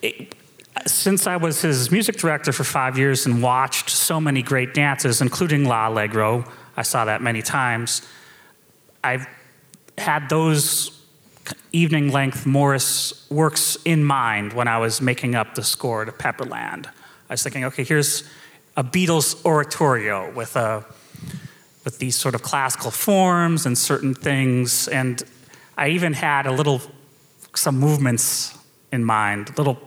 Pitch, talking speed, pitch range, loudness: 140 Hz, 145 wpm, 125-150 Hz, -20 LUFS